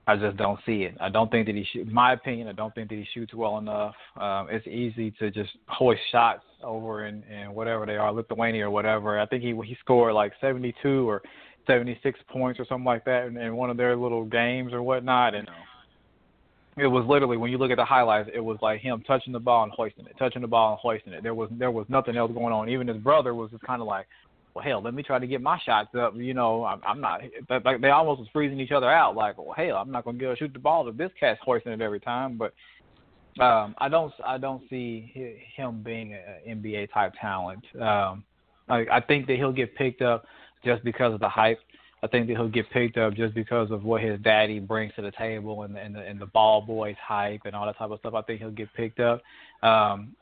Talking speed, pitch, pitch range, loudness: 255 wpm, 115 Hz, 110-125 Hz, -26 LUFS